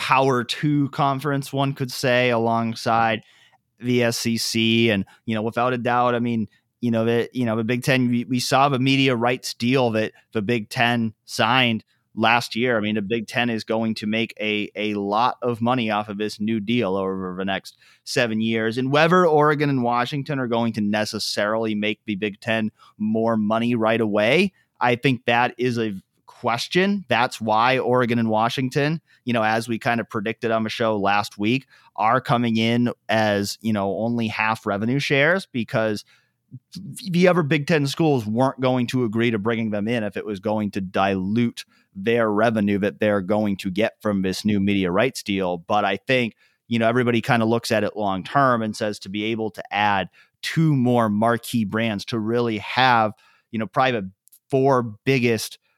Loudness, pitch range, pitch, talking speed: -22 LUFS, 110-125 Hz, 115 Hz, 190 wpm